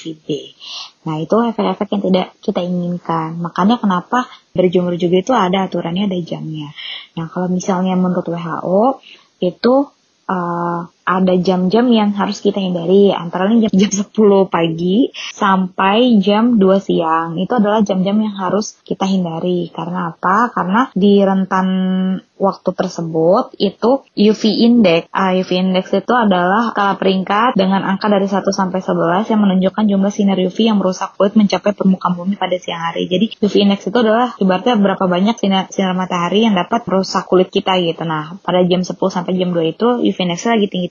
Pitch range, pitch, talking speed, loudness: 180-205 Hz, 190 Hz, 165 wpm, -15 LUFS